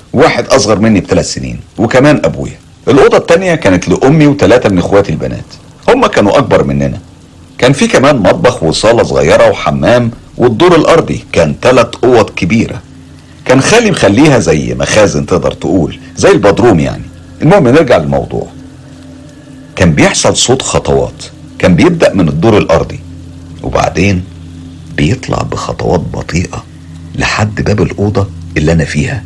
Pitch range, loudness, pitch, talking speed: 80-100 Hz, -9 LUFS, 85 Hz, 130 wpm